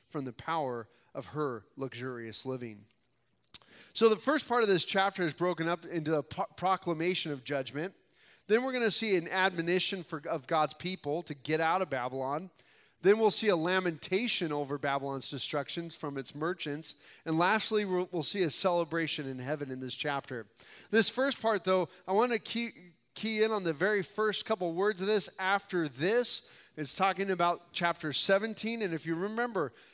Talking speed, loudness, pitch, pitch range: 175 wpm, -31 LUFS, 170 Hz, 145-195 Hz